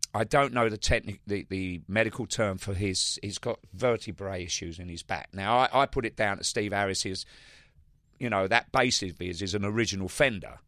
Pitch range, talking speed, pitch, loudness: 95-115 Hz, 210 wpm, 100 Hz, -28 LUFS